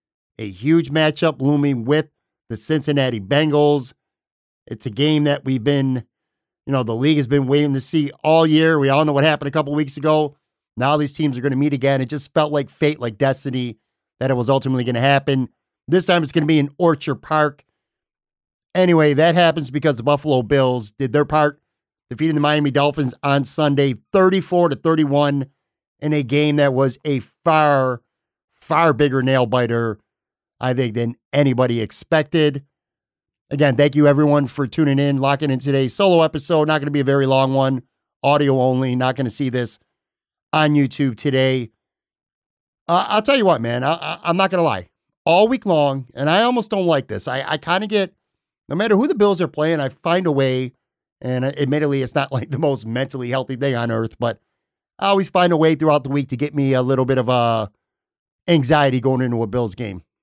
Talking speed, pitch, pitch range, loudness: 200 wpm, 145 Hz, 130-155 Hz, -18 LUFS